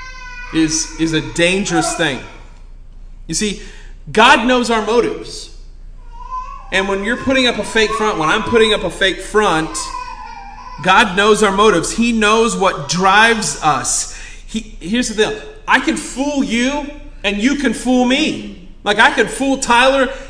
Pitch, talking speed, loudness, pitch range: 230 Hz, 155 wpm, -14 LUFS, 200-280 Hz